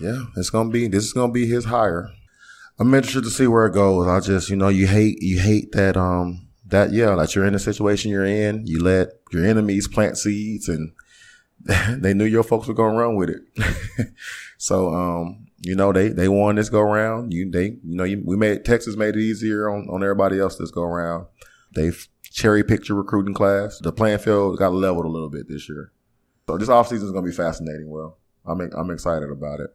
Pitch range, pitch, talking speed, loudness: 90-110 Hz, 100 Hz, 230 wpm, -20 LUFS